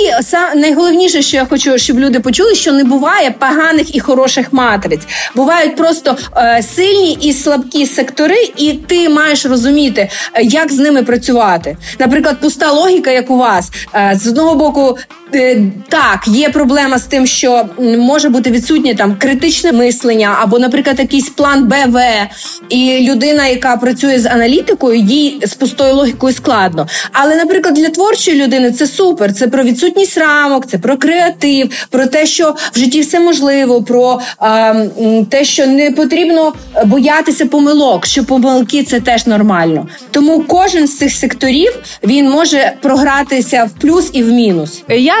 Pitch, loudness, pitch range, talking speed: 270 Hz, -9 LUFS, 245-305 Hz, 150 wpm